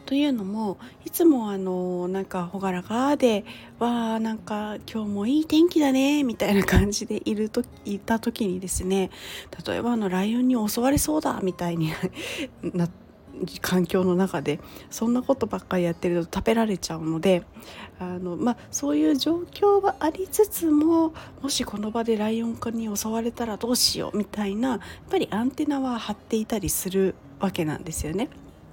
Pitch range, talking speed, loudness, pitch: 190-260 Hz, 345 characters per minute, -25 LUFS, 220 Hz